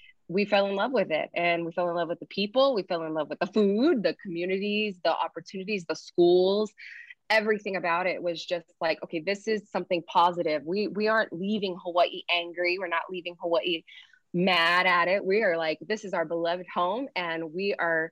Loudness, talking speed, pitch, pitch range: -27 LUFS, 205 wpm, 180 Hz, 170-200 Hz